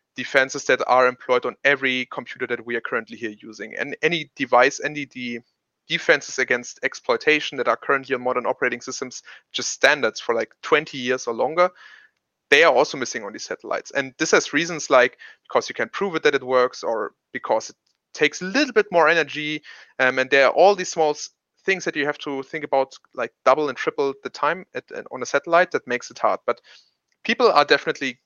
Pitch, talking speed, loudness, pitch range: 150 Hz, 210 wpm, -21 LUFS, 130-170 Hz